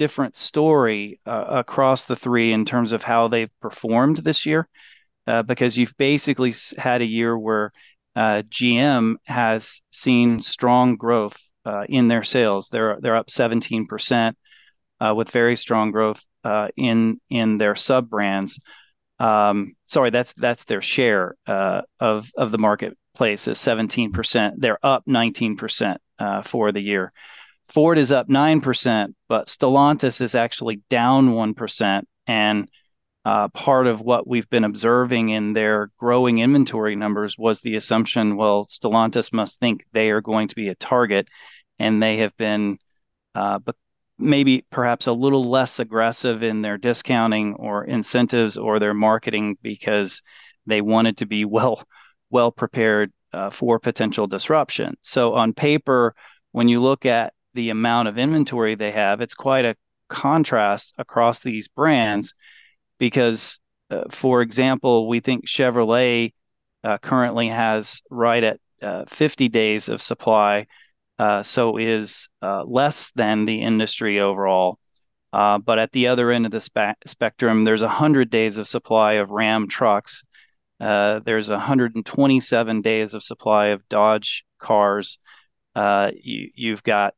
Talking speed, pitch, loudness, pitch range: 145 wpm, 115 Hz, -20 LUFS, 105-125 Hz